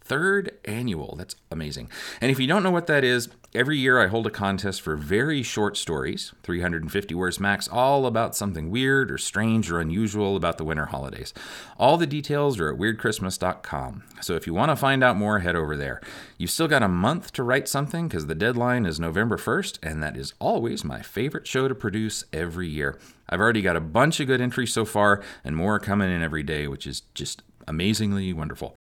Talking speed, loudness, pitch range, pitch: 210 wpm, -24 LUFS, 85-125 Hz, 105 Hz